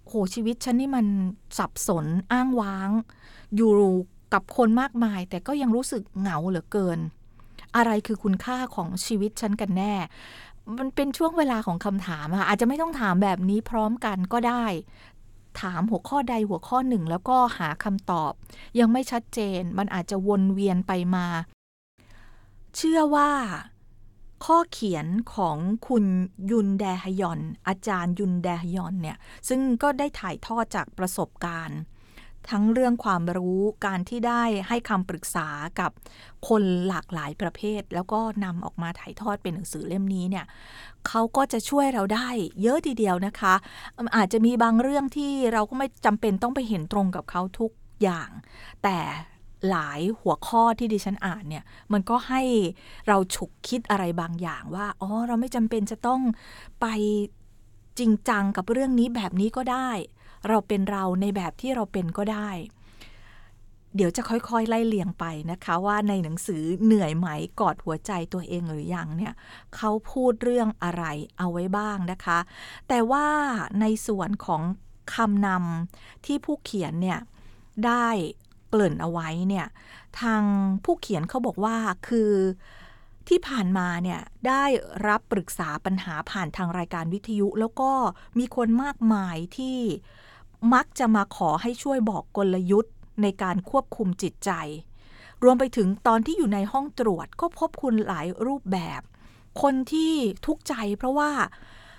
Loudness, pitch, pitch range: -26 LUFS, 205 Hz, 180-235 Hz